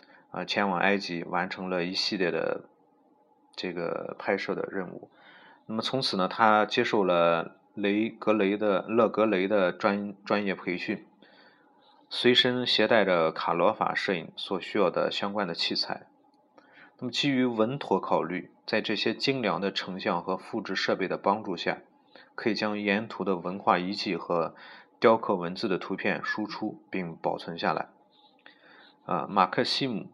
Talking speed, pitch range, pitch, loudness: 230 characters per minute, 95-120 Hz, 105 Hz, -28 LUFS